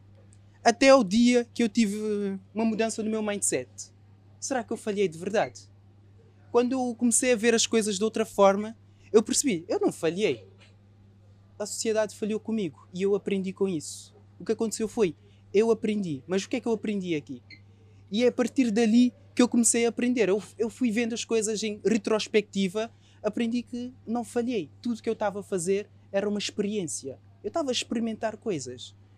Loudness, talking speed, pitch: -27 LUFS, 190 wpm, 210 Hz